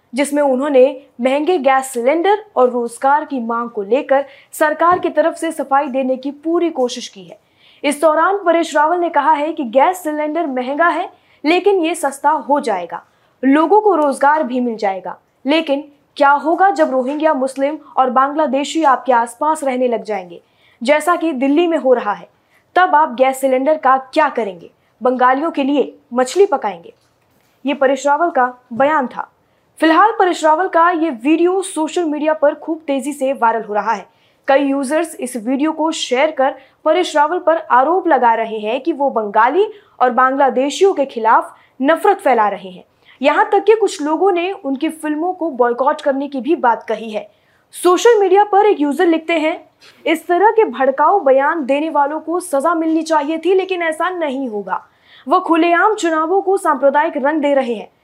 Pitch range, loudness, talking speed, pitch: 265-330 Hz, -15 LUFS, 180 wpm, 295 Hz